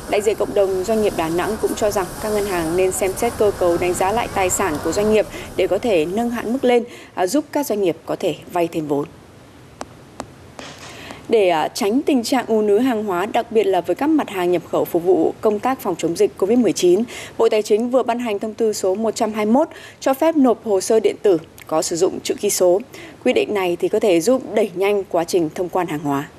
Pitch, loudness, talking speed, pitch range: 210 Hz, -19 LUFS, 240 wpm, 185-240 Hz